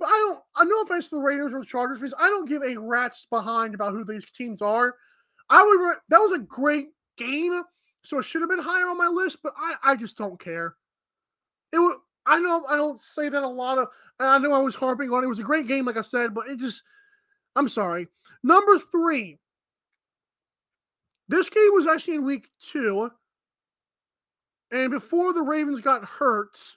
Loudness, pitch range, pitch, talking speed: -23 LUFS, 245-345 Hz, 280 Hz, 210 wpm